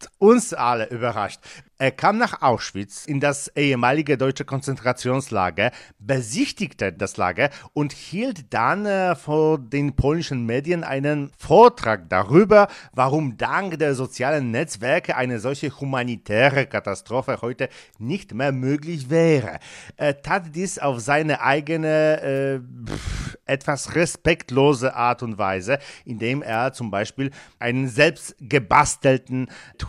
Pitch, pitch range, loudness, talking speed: 135 Hz, 120-150 Hz, -21 LUFS, 115 wpm